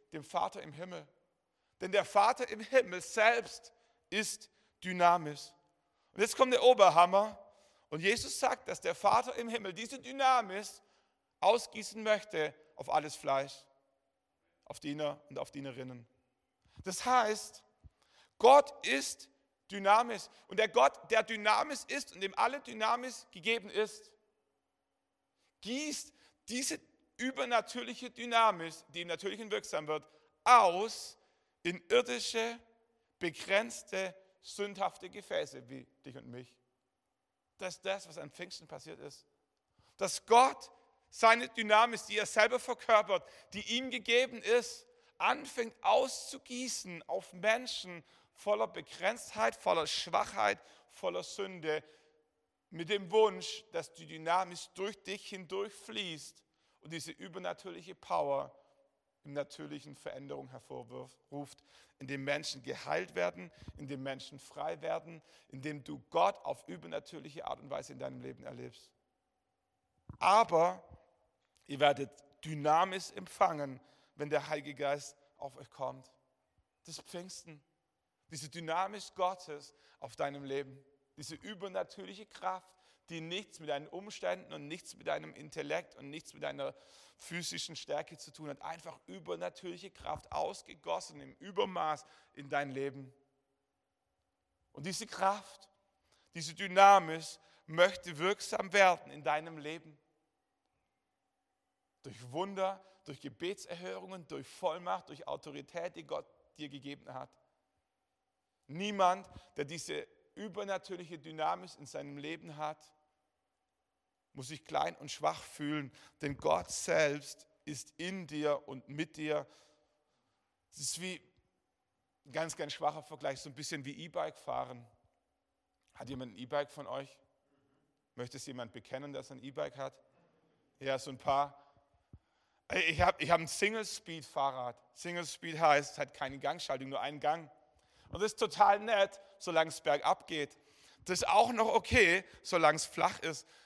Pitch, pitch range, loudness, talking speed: 170 Hz, 145-215 Hz, -34 LUFS, 125 wpm